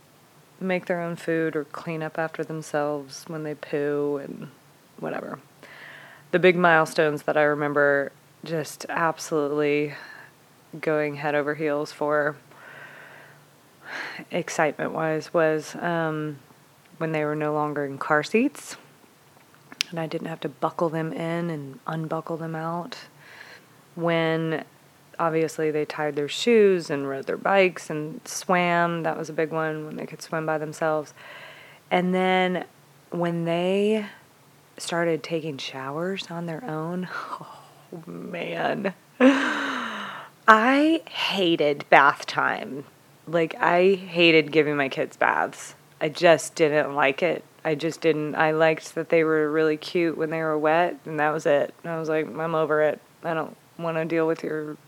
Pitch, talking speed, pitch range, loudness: 160 Hz, 145 wpm, 150-170 Hz, -24 LUFS